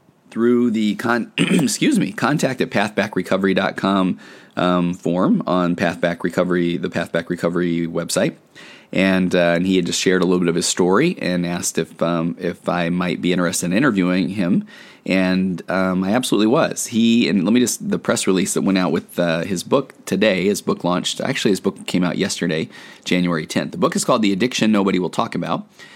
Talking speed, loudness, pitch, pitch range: 195 wpm, -19 LUFS, 90 Hz, 85-95 Hz